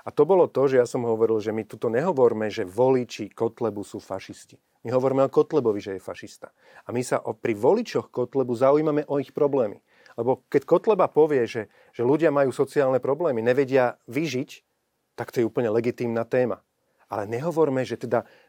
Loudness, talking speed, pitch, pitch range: -24 LUFS, 185 wpm, 125 Hz, 115-140 Hz